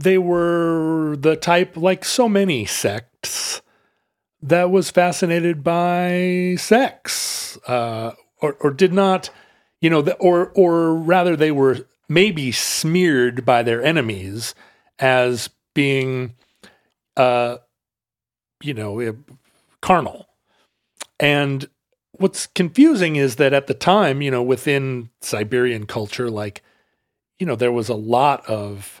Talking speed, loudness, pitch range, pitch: 120 wpm, -18 LUFS, 125-180 Hz, 145 Hz